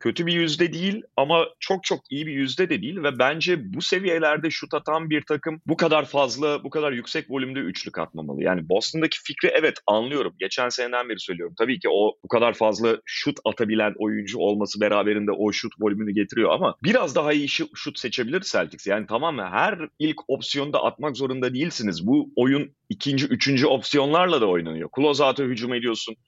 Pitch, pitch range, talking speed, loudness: 140 Hz, 115-155 Hz, 185 wpm, -23 LUFS